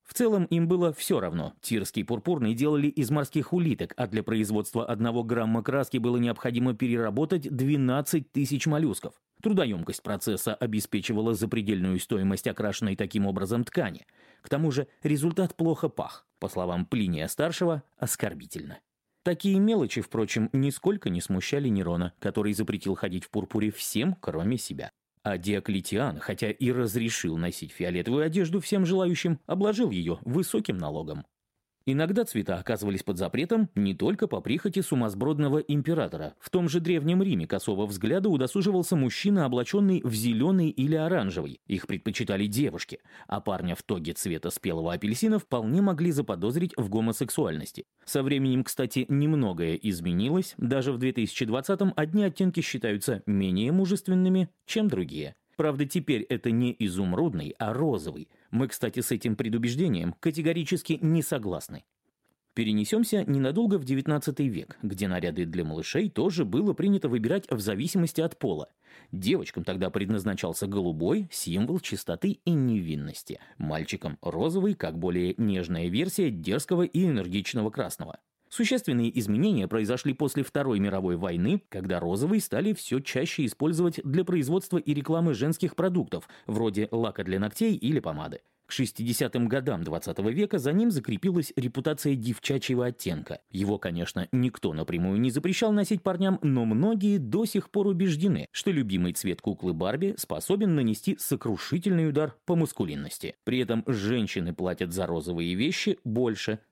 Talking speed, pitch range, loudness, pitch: 140 wpm, 105-170 Hz, -28 LUFS, 130 Hz